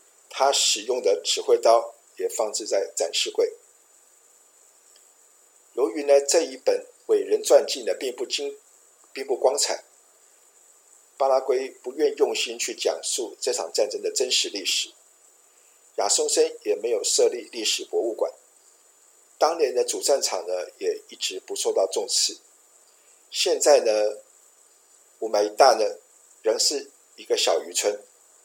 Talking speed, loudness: 195 characters per minute, -23 LUFS